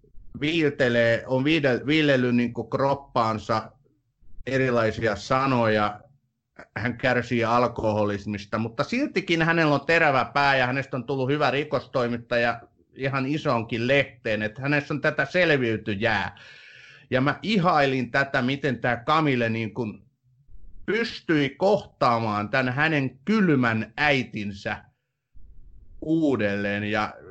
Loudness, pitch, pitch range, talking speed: -24 LUFS, 125 Hz, 115-145 Hz, 105 wpm